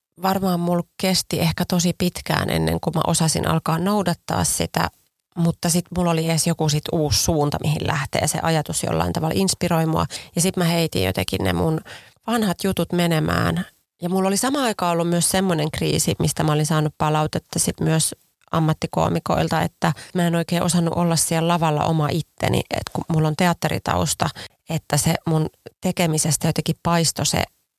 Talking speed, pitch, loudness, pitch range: 170 wpm, 165 Hz, -21 LUFS, 155-175 Hz